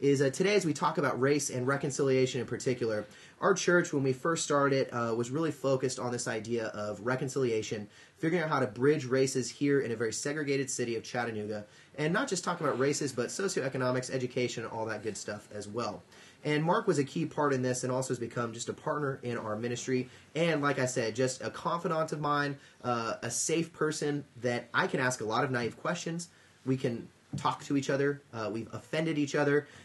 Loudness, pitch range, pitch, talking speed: -32 LUFS, 120-145 Hz, 130 Hz, 215 wpm